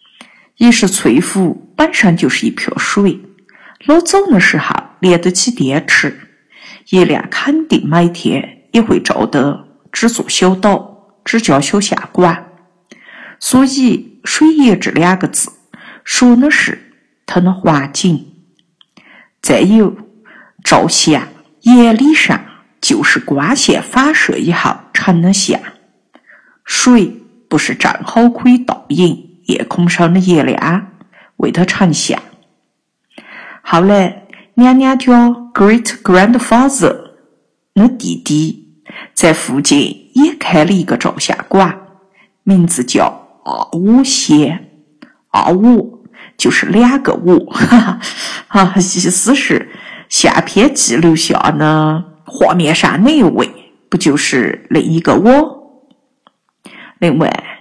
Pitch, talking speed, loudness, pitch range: 205 Hz, 175 characters per minute, -11 LUFS, 180-250 Hz